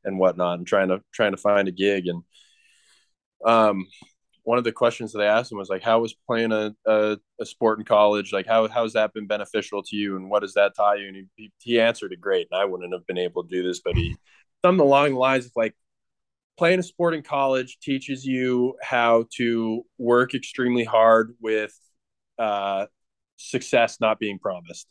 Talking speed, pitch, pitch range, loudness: 210 wpm, 110 Hz, 100-125 Hz, -23 LUFS